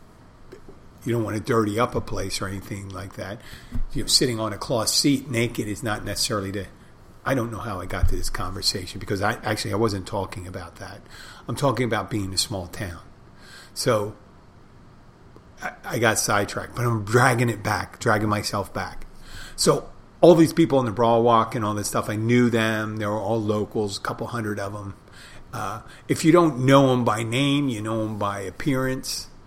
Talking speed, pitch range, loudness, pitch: 200 wpm, 100-120 Hz, -23 LUFS, 110 Hz